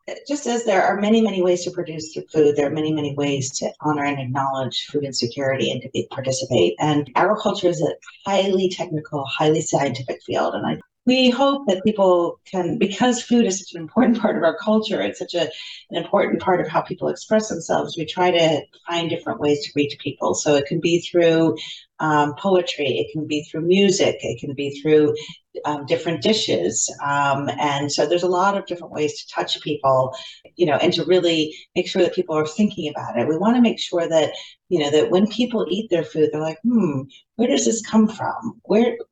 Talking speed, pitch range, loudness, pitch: 210 wpm, 150-195 Hz, -20 LUFS, 165 Hz